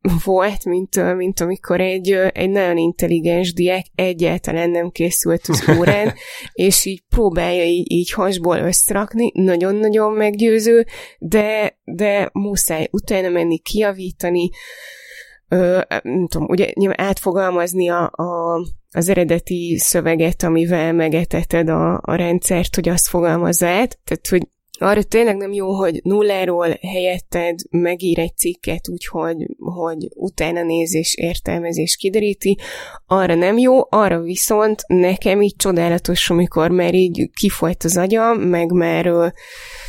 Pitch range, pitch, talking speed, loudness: 170-195 Hz, 180 Hz, 120 wpm, -17 LUFS